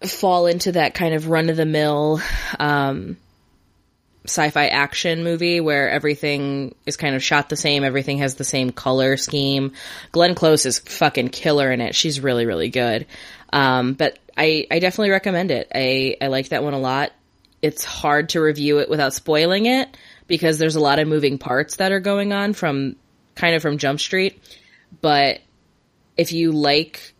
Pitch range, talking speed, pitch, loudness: 135-165 Hz, 180 wpm, 150 Hz, -19 LUFS